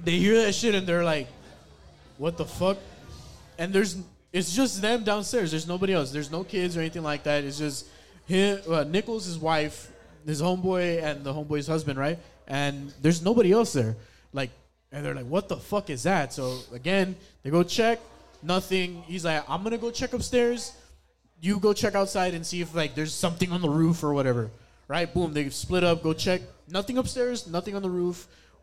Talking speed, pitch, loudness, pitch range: 200 wpm, 175 Hz, -27 LUFS, 150-195 Hz